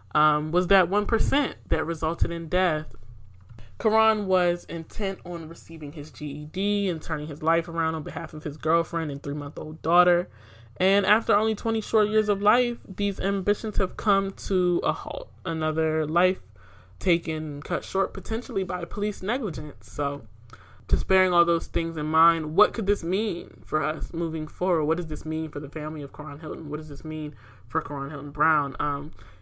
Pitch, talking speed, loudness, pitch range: 165 Hz, 180 wpm, -26 LUFS, 150-190 Hz